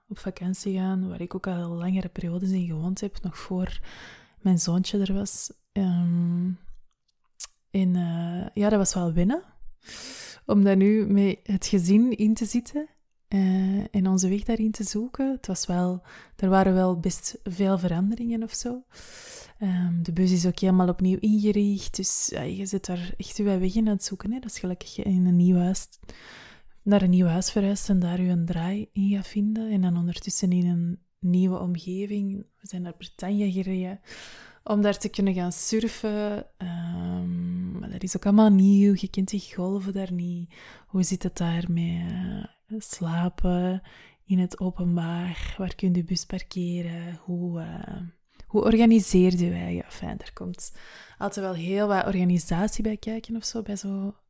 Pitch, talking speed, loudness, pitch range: 190 Hz, 180 wpm, -25 LUFS, 180-205 Hz